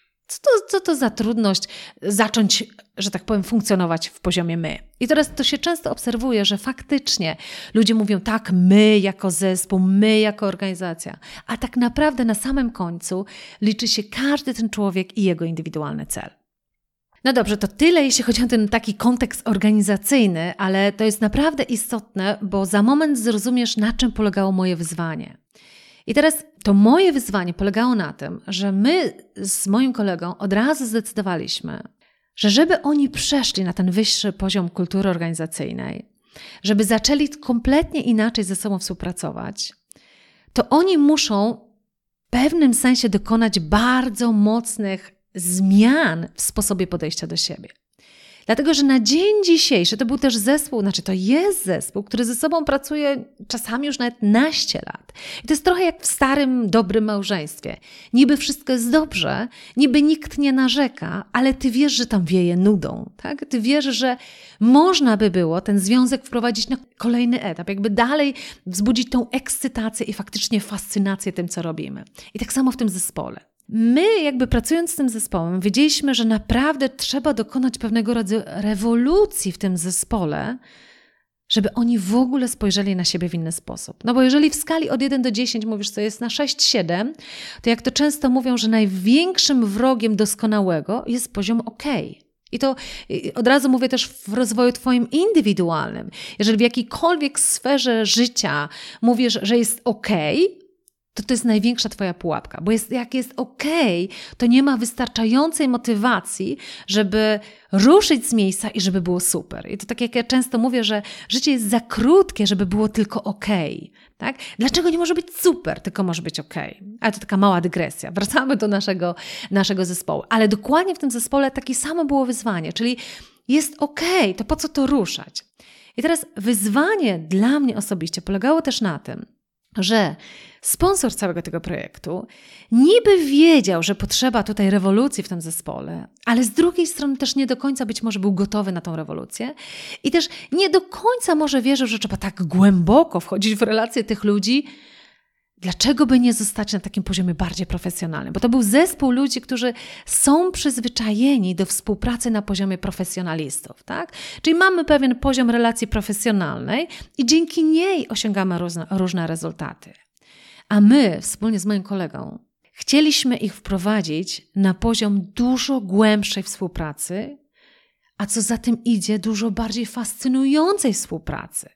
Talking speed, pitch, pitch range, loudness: 160 wpm, 225 Hz, 200-270 Hz, -19 LUFS